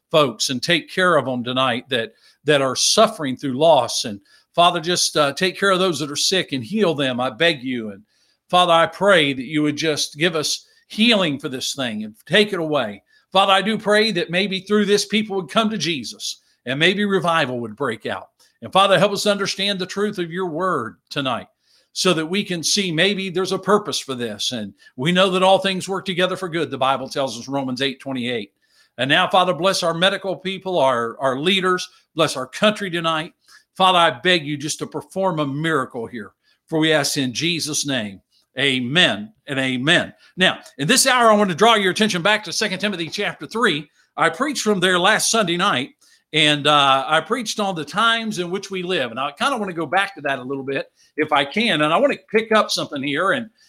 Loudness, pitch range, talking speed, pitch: -19 LUFS, 145-195 Hz, 220 wpm, 180 Hz